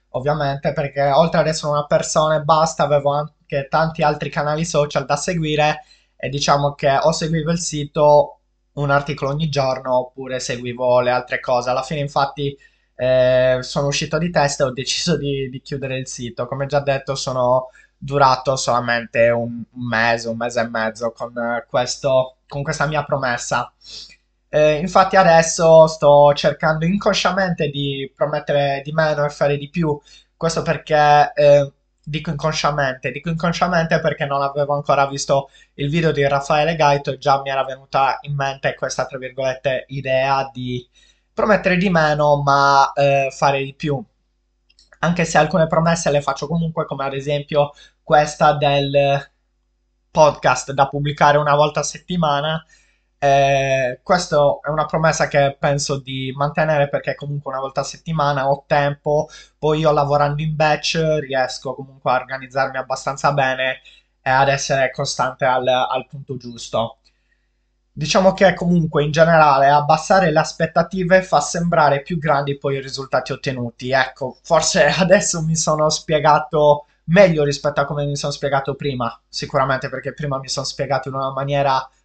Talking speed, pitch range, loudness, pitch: 155 wpm, 135-155 Hz, -18 LUFS, 145 Hz